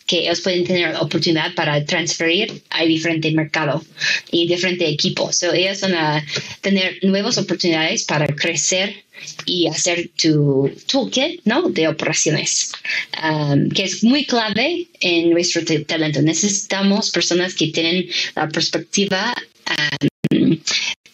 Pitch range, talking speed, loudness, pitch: 160-190 Hz, 130 wpm, -18 LUFS, 170 Hz